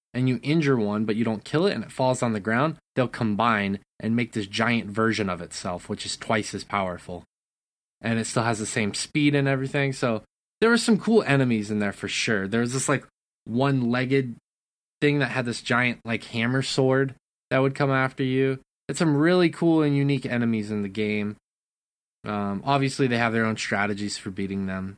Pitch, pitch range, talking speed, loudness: 120 Hz, 105-135 Hz, 205 wpm, -25 LUFS